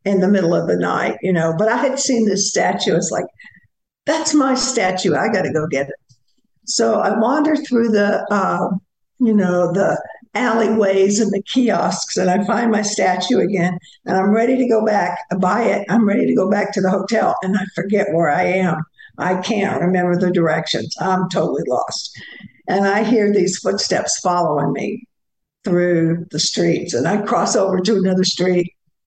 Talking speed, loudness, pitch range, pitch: 190 wpm, -17 LUFS, 180-220 Hz, 195 Hz